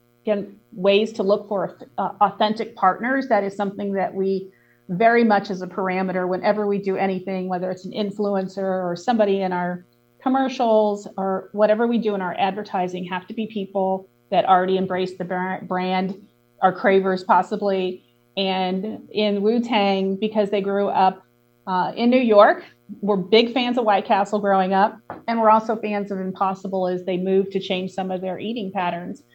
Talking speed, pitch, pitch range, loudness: 180 wpm, 195 Hz, 185-210 Hz, -21 LUFS